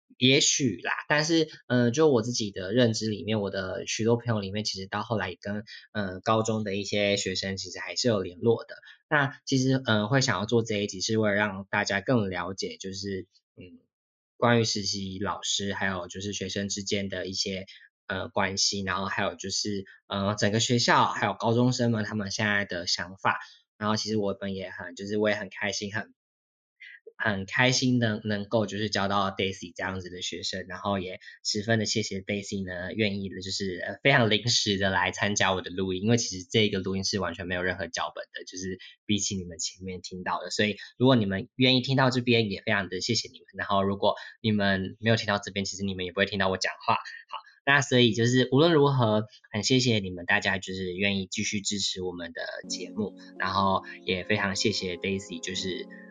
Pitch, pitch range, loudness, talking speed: 100 Hz, 95-115 Hz, -27 LUFS, 325 characters per minute